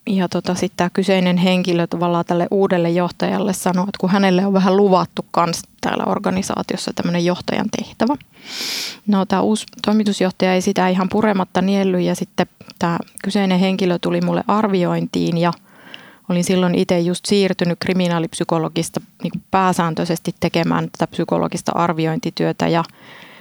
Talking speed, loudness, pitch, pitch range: 140 wpm, -18 LUFS, 185 Hz, 175-195 Hz